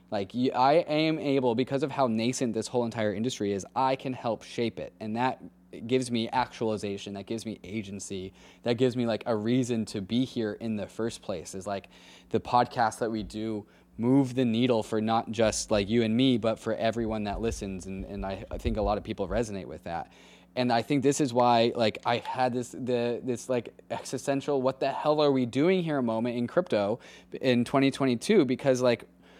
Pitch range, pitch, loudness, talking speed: 105-130 Hz, 115 Hz, -28 LUFS, 210 wpm